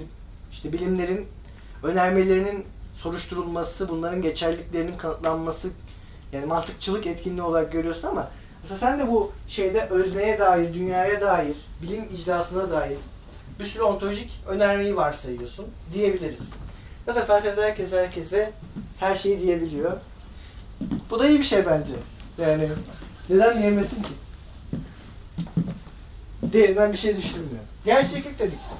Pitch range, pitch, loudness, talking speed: 165-200 Hz, 180 Hz, -24 LUFS, 115 wpm